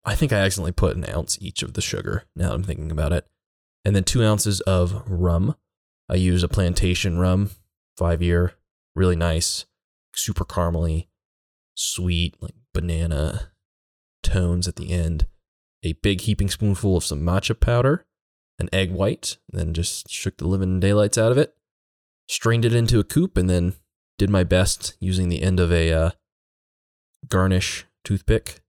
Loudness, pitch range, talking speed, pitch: -22 LUFS, 85-95 Hz, 165 wpm, 90 Hz